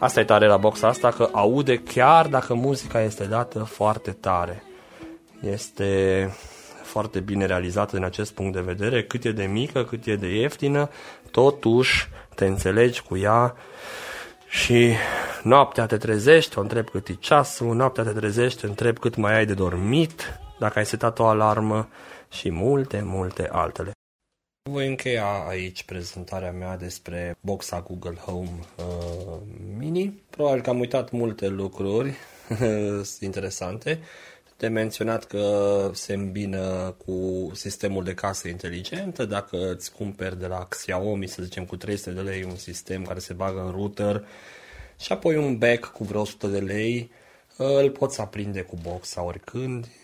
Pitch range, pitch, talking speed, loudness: 95-120 Hz, 105 Hz, 150 wpm, -24 LUFS